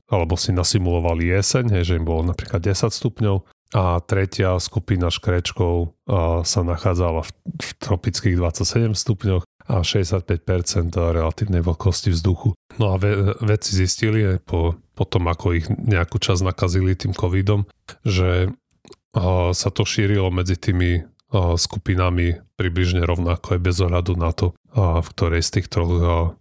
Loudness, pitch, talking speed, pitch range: -20 LUFS, 95 Hz, 130 wpm, 85-105 Hz